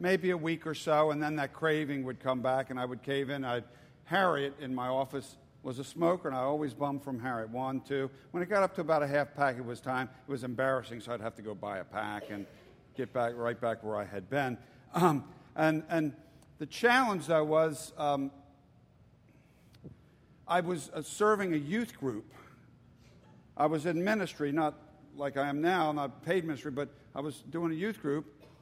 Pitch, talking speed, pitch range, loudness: 145 Hz, 210 wpm, 130-160 Hz, -33 LUFS